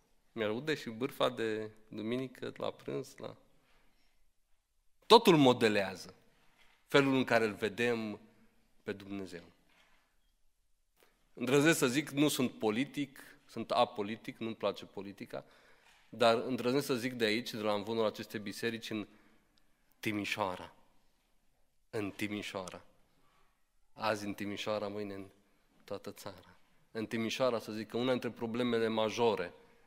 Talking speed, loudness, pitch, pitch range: 120 wpm, -33 LUFS, 110 Hz, 100-120 Hz